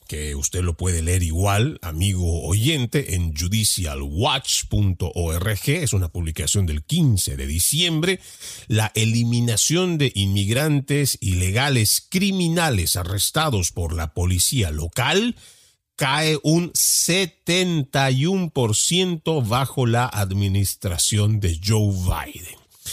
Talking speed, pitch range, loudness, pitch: 95 wpm, 90-145 Hz, -20 LUFS, 105 Hz